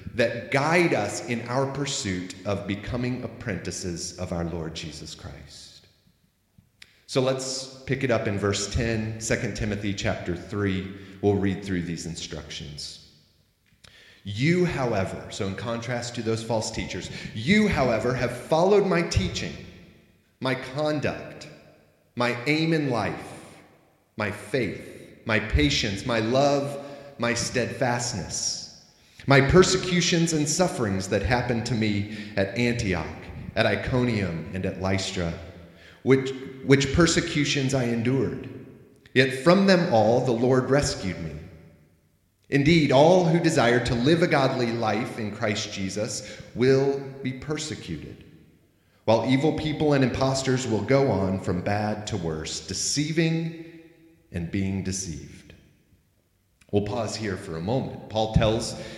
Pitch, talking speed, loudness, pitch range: 115 Hz, 130 wpm, -25 LUFS, 95-135 Hz